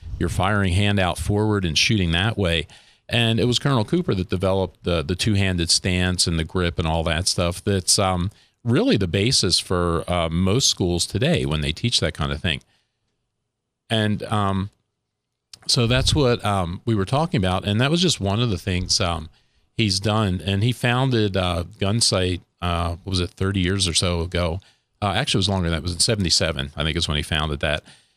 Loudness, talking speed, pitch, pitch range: -21 LUFS, 210 wpm, 95 Hz, 85-110 Hz